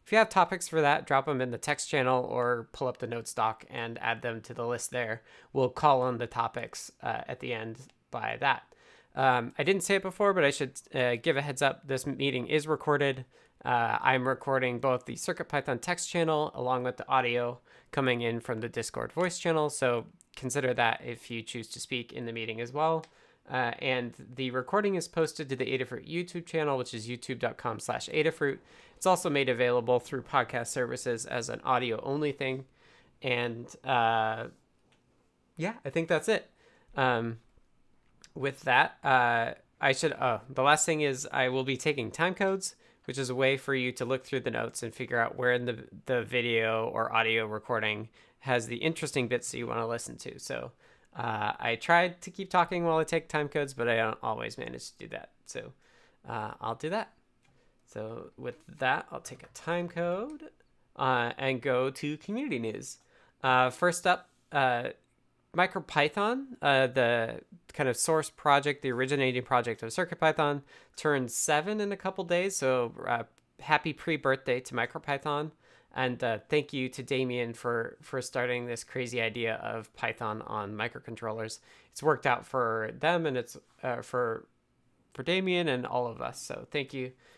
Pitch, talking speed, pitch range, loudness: 130 Hz, 185 wpm, 120-155 Hz, -30 LUFS